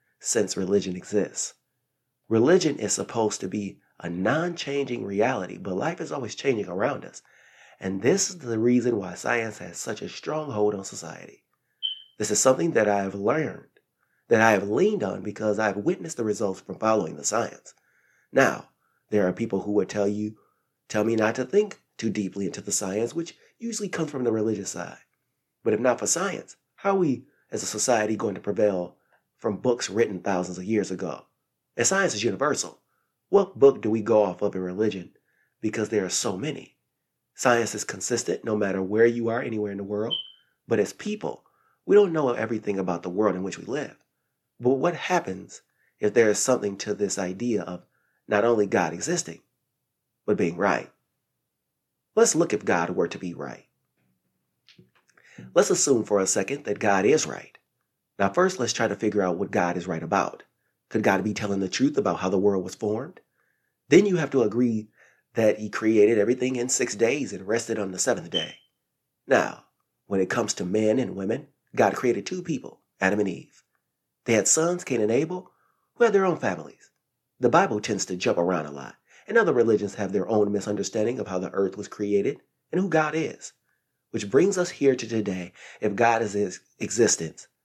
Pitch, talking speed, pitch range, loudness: 105 Hz, 195 wpm, 95-125 Hz, -25 LUFS